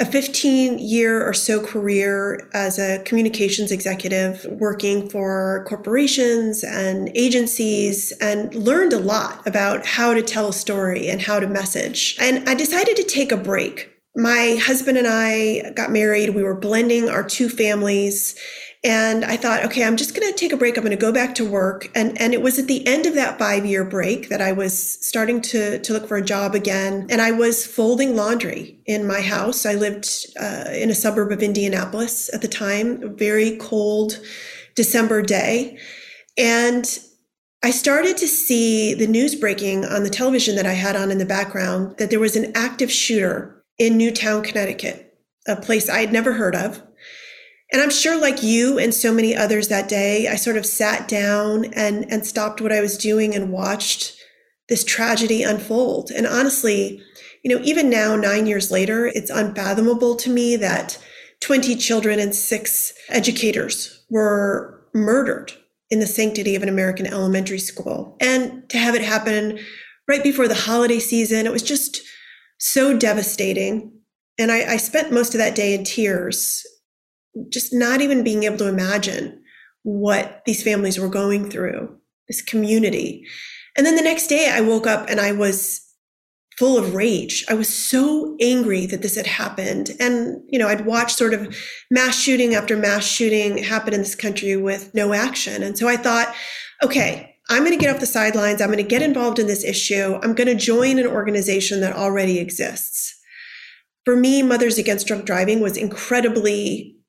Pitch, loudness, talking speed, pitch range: 220 Hz, -19 LUFS, 180 wpm, 205-245 Hz